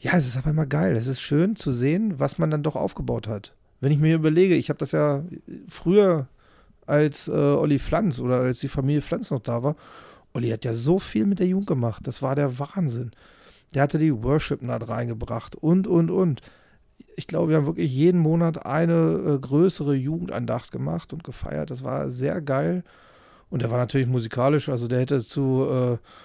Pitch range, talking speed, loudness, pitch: 125-165 Hz, 195 wpm, -24 LUFS, 145 Hz